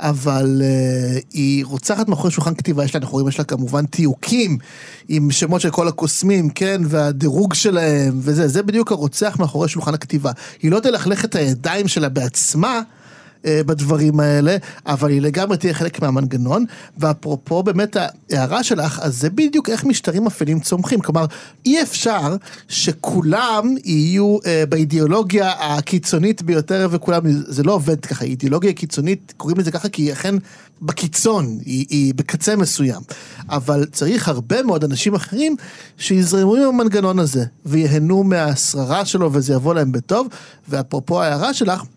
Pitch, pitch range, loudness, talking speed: 165 Hz, 145-195 Hz, -17 LUFS, 145 wpm